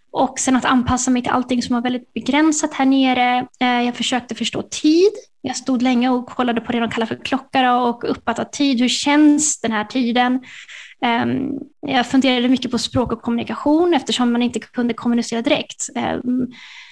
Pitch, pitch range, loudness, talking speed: 255 Hz, 245-270 Hz, -18 LUFS, 175 wpm